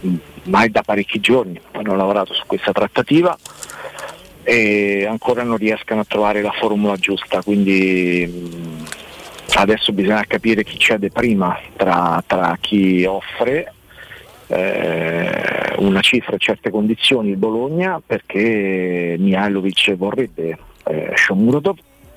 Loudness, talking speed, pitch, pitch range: -17 LUFS, 115 wpm, 100 Hz, 90-110 Hz